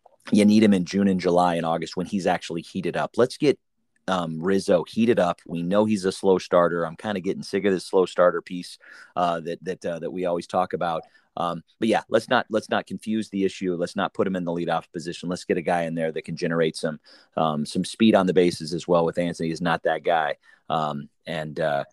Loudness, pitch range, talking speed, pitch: -24 LUFS, 85-95 Hz, 245 wpm, 85 Hz